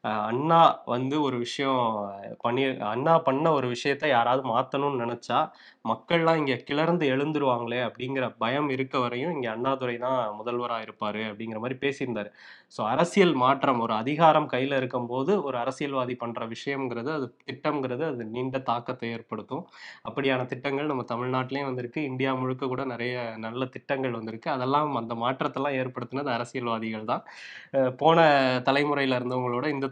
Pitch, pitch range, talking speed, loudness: 130 Hz, 120-140 Hz, 135 wpm, -27 LUFS